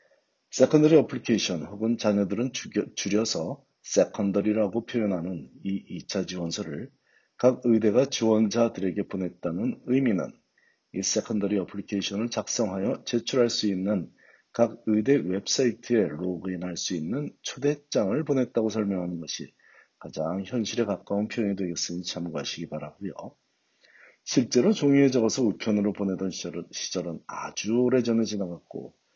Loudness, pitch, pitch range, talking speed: -27 LUFS, 105 Hz, 95-120 Hz, 330 characters per minute